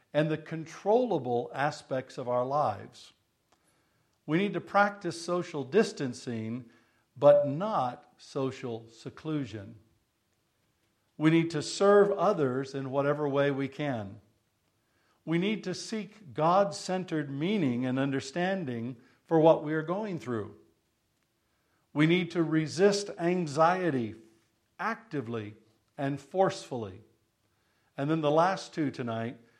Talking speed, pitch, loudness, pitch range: 115 wpm, 140 Hz, -29 LUFS, 115-170 Hz